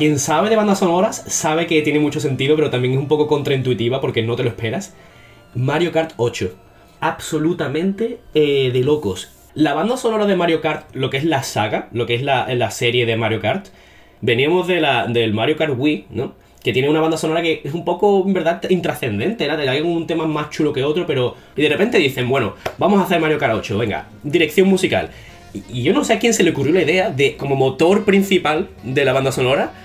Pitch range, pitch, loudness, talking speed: 125-170 Hz, 150 Hz, -18 LUFS, 225 wpm